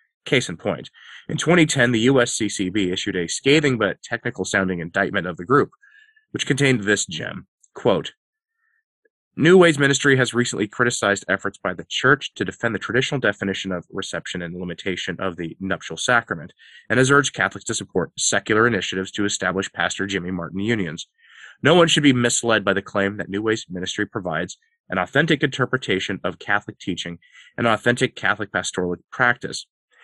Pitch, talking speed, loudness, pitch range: 110 Hz, 165 wpm, -21 LUFS, 95-140 Hz